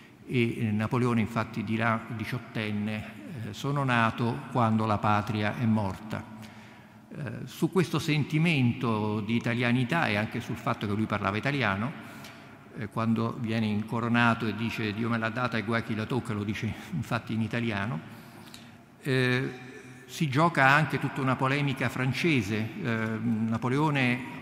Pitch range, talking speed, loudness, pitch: 110-125 Hz, 140 wpm, -28 LUFS, 115 Hz